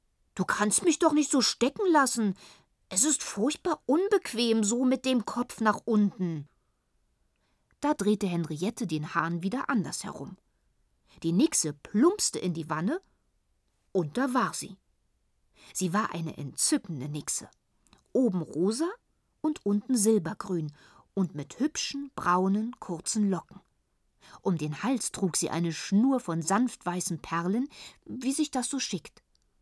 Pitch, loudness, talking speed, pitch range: 210 Hz, -29 LUFS, 140 wpm, 175-260 Hz